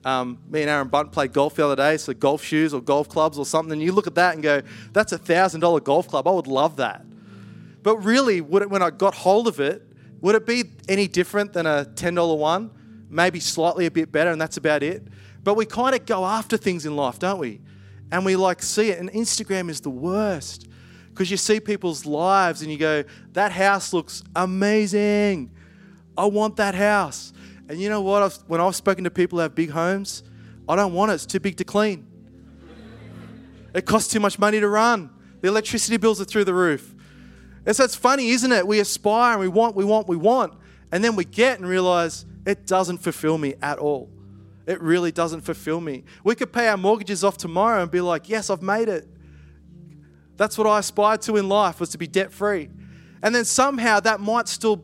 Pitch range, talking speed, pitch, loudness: 155-210 Hz, 220 wpm, 180 Hz, -21 LUFS